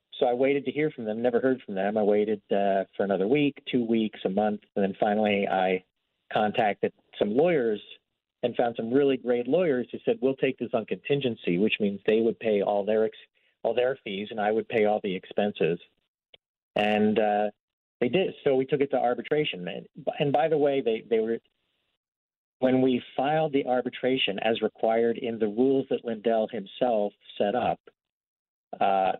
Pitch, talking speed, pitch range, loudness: 115 Hz, 190 wpm, 105-130 Hz, -27 LUFS